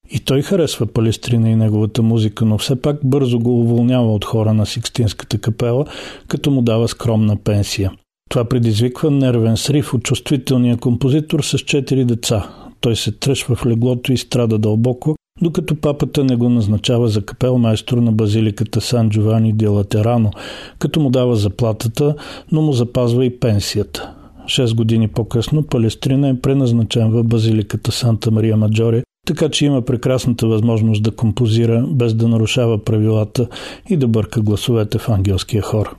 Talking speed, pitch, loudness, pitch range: 155 wpm, 120 Hz, -16 LUFS, 110-130 Hz